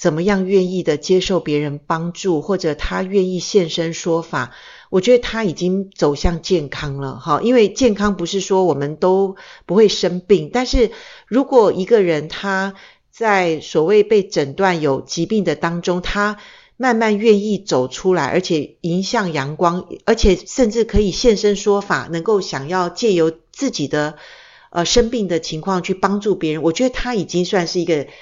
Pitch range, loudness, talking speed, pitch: 165-210 Hz, -17 LUFS, 255 characters per minute, 185 Hz